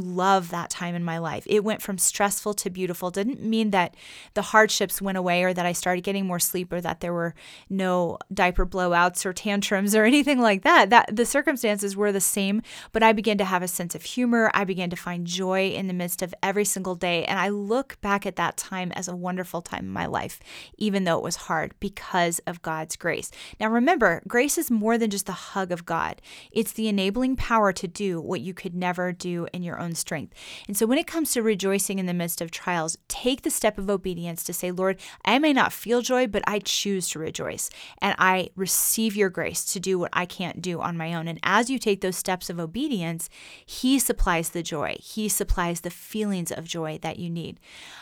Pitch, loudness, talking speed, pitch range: 190 Hz, -25 LUFS, 225 wpm, 175-210 Hz